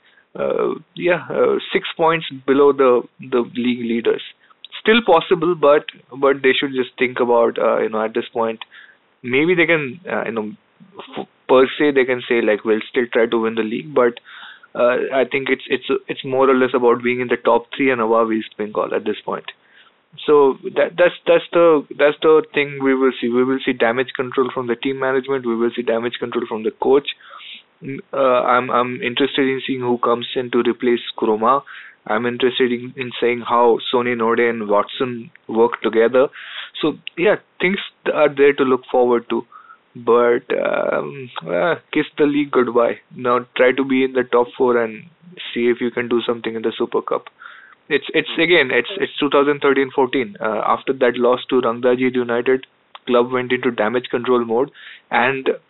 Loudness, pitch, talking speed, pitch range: -18 LUFS, 125 Hz, 190 wpm, 120-140 Hz